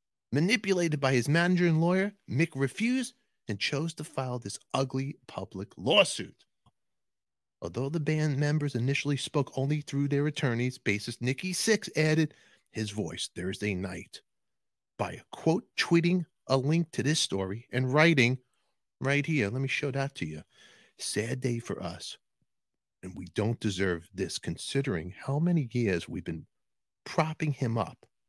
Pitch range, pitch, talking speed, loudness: 115-155 Hz, 135 Hz, 150 wpm, -30 LUFS